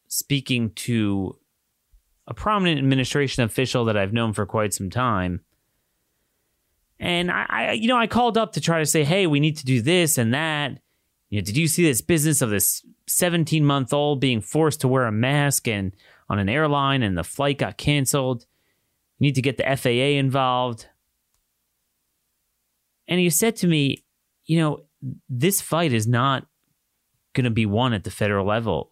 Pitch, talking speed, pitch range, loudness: 130 Hz, 175 wpm, 105-155 Hz, -22 LUFS